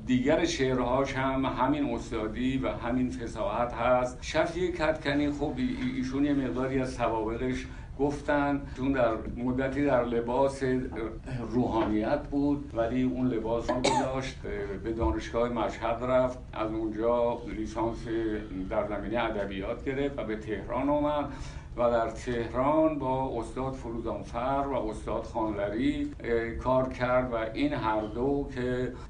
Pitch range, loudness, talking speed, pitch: 115-135 Hz, -30 LUFS, 130 wpm, 125 Hz